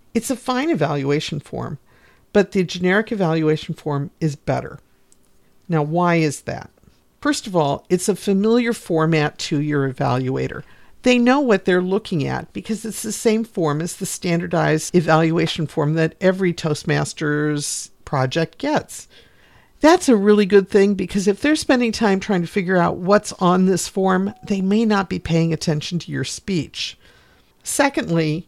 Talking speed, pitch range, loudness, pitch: 160 wpm, 155-210 Hz, -19 LUFS, 180 Hz